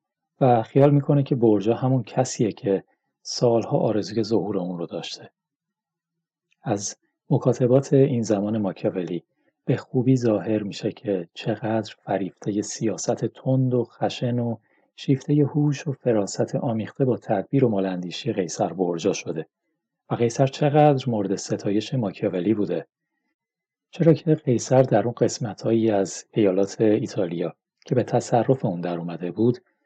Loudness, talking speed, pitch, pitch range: -23 LUFS, 135 wpm, 120 Hz, 105-135 Hz